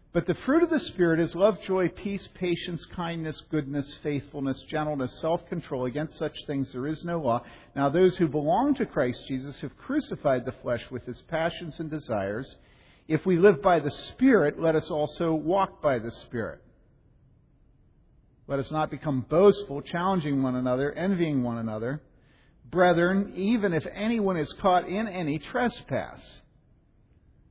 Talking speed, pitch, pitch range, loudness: 160 wpm, 155 Hz, 140-180 Hz, -27 LUFS